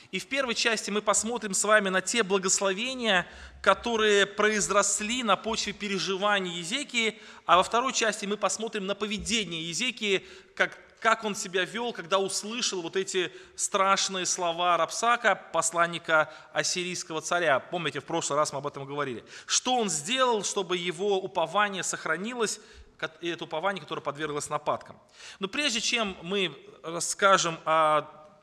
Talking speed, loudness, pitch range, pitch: 140 wpm, -27 LUFS, 170-215 Hz, 195 Hz